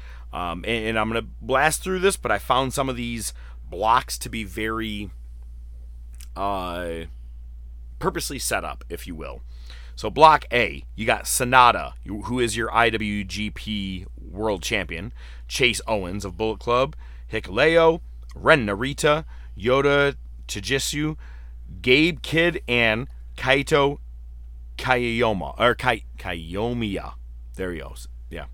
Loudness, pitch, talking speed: -22 LUFS, 95 Hz, 125 wpm